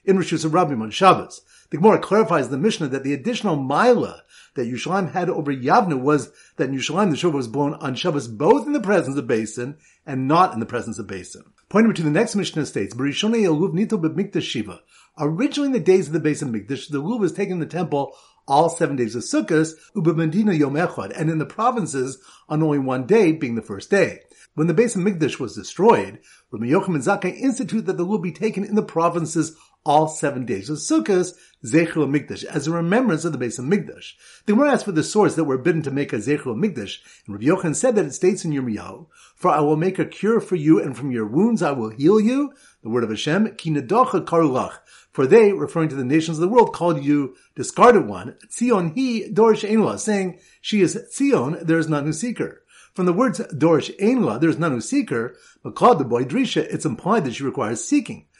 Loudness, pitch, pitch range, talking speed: -20 LUFS, 165 Hz, 145-210 Hz, 215 wpm